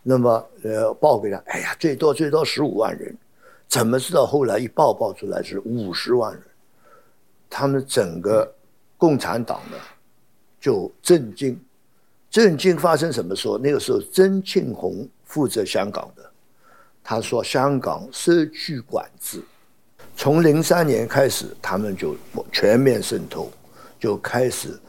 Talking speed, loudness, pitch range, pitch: 210 characters per minute, -21 LUFS, 130-190 Hz, 155 Hz